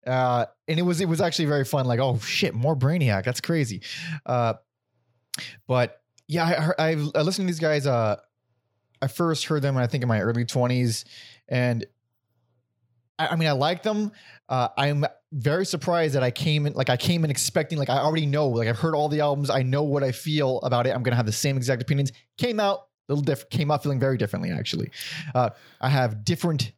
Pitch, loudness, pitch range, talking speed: 135 Hz, -25 LUFS, 125-155 Hz, 215 wpm